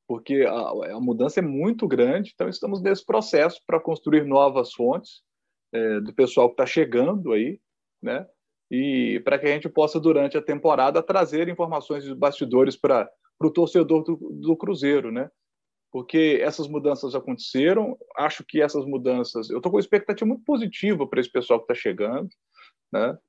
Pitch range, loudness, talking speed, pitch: 140-210 Hz, -23 LUFS, 170 wpm, 160 Hz